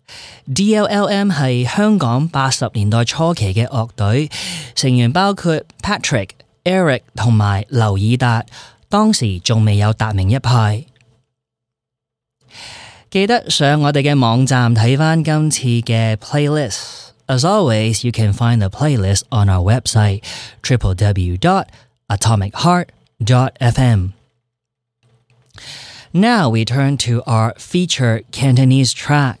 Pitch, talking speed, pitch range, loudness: 125 Hz, 105 wpm, 110-145 Hz, -15 LUFS